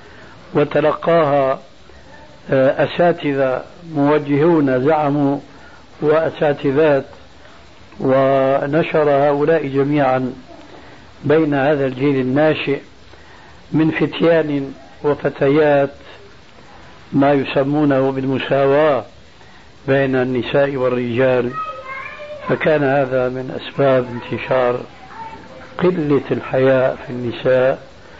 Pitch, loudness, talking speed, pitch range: 140 Hz, -17 LUFS, 65 wpm, 130-150 Hz